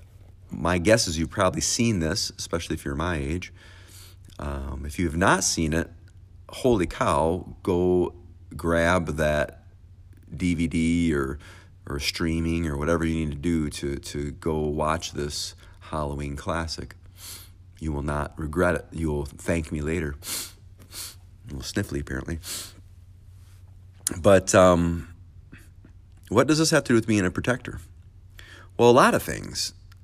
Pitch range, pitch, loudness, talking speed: 80-95 Hz, 90 Hz, -25 LUFS, 145 wpm